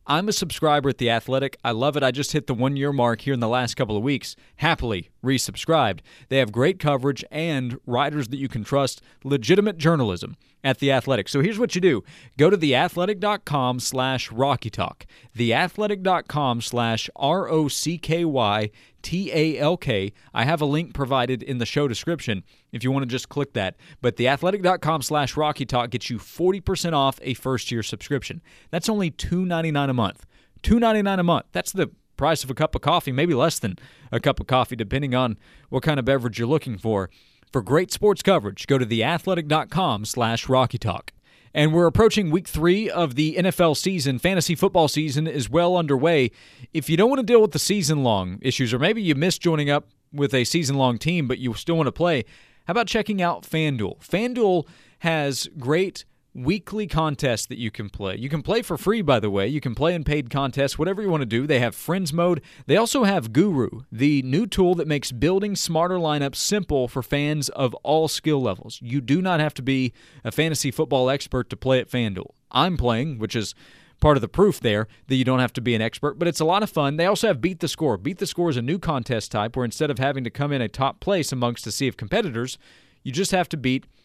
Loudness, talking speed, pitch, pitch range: -23 LUFS, 215 wpm, 140 Hz, 125-170 Hz